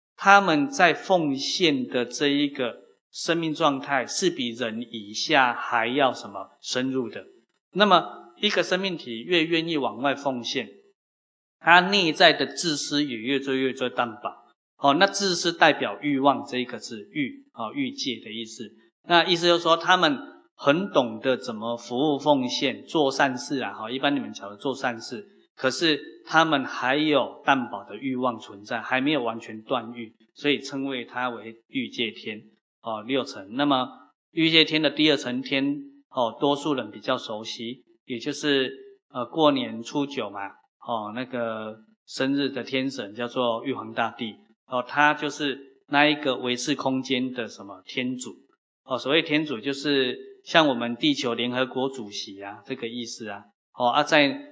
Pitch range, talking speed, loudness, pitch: 120-155 Hz, 235 characters per minute, -24 LUFS, 135 Hz